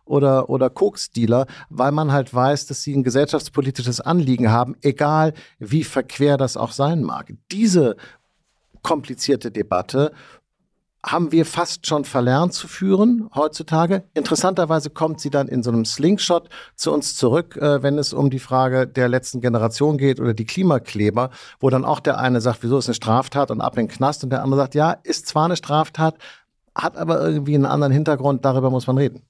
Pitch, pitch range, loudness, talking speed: 140 Hz, 130-155 Hz, -19 LUFS, 180 wpm